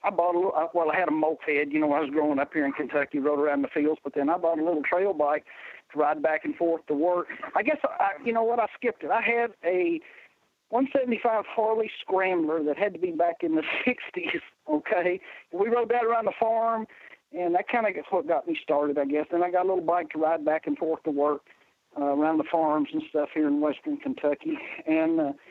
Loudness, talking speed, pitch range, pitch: -27 LUFS, 245 wpm, 150-230 Hz, 175 Hz